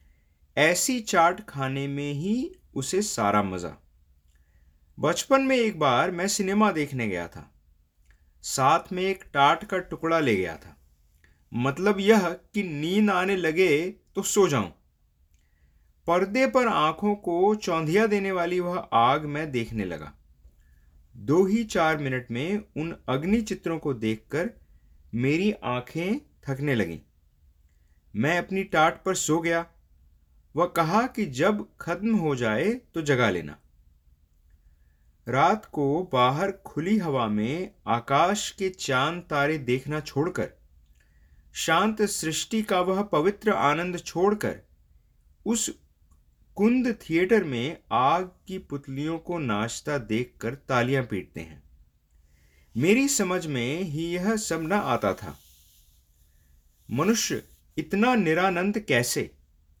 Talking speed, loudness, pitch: 120 wpm, -25 LUFS, 145 Hz